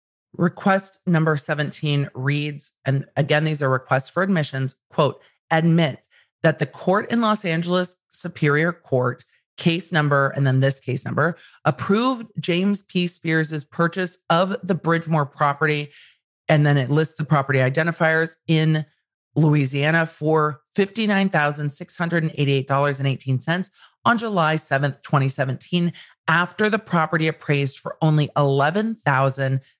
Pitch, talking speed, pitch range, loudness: 155 Hz, 120 wpm, 140-175 Hz, -21 LUFS